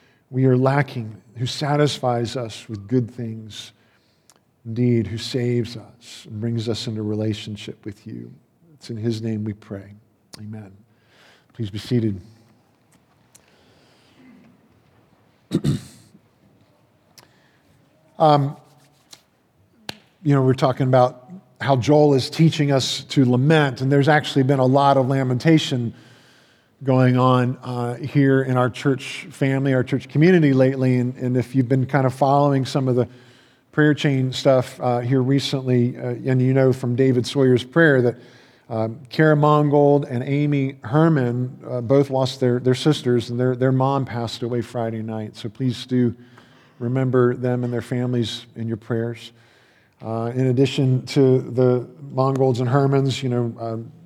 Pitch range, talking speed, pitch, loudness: 120-135 Hz, 145 wpm, 125 Hz, -20 LUFS